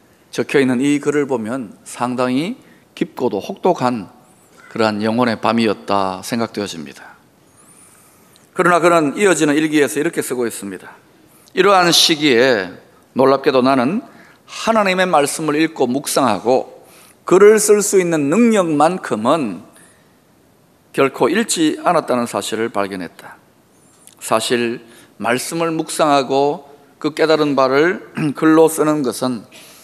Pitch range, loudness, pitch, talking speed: 125-175 Hz, -16 LUFS, 145 Hz, 260 characters per minute